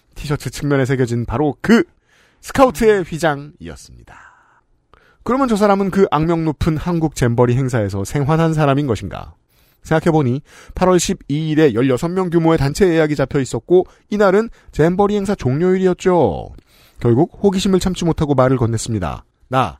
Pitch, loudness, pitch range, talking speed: 155 Hz, -16 LUFS, 130-185 Hz, 330 characters per minute